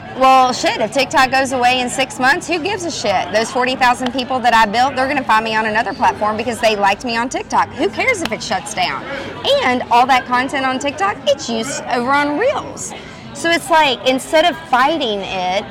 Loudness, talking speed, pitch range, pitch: -15 LUFS, 215 wpm, 230-280 Hz, 255 Hz